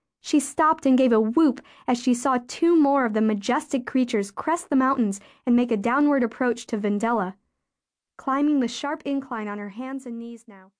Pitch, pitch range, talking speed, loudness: 250 Hz, 225-280 Hz, 195 wpm, -23 LUFS